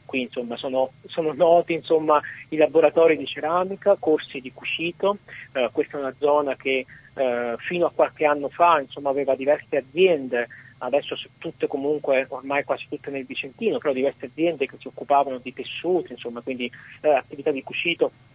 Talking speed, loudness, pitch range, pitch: 165 wpm, -23 LUFS, 130-160 Hz, 145 Hz